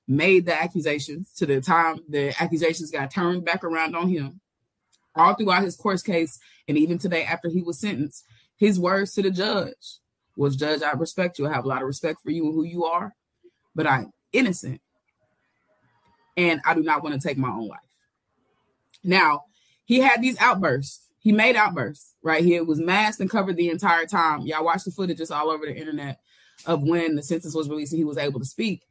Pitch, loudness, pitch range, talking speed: 165 Hz, -23 LUFS, 150-185 Hz, 205 wpm